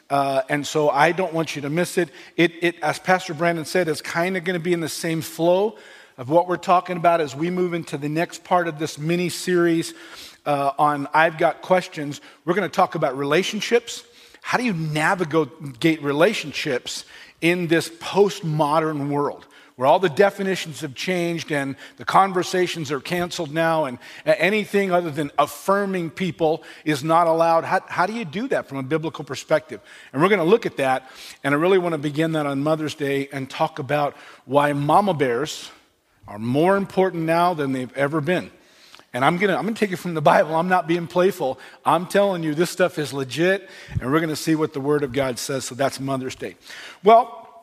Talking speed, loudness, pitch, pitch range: 205 wpm, -21 LUFS, 165 Hz, 150-180 Hz